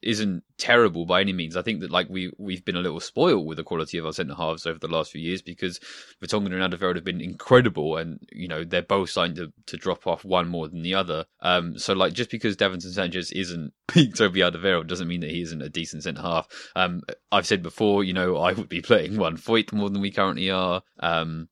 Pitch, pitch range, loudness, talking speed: 90 Hz, 85-95 Hz, -25 LUFS, 240 wpm